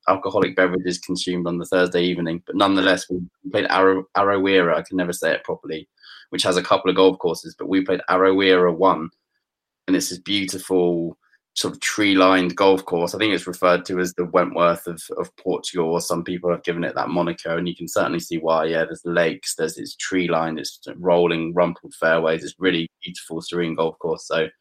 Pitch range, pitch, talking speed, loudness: 85-95 Hz, 90 Hz, 200 wpm, -21 LUFS